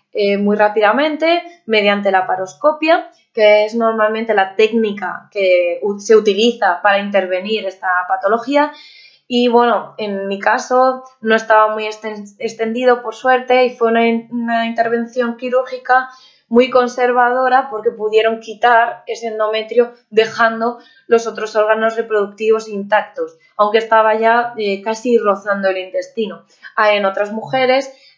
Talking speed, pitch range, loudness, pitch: 130 wpm, 210-245 Hz, -15 LUFS, 225 Hz